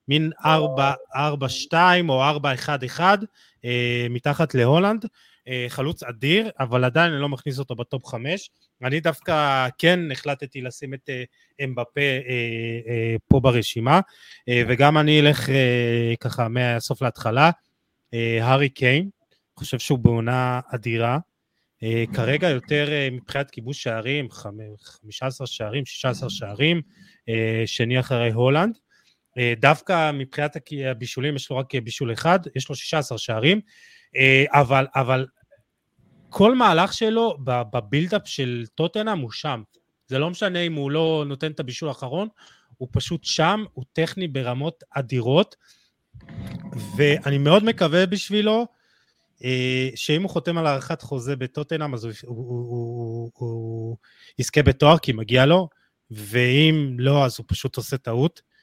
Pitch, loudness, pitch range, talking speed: 135 Hz, -22 LUFS, 125-155 Hz, 120 wpm